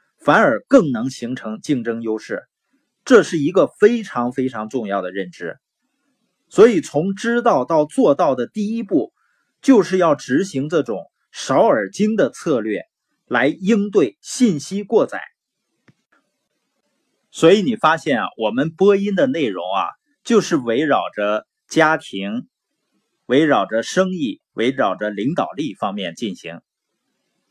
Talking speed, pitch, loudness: 200 characters per minute, 185 Hz, -18 LUFS